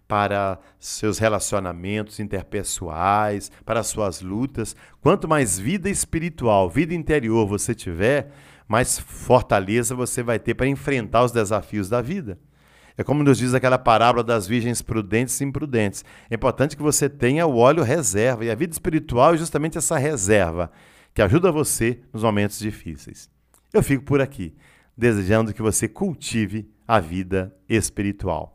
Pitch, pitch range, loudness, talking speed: 115 Hz, 105-135 Hz, -21 LUFS, 145 wpm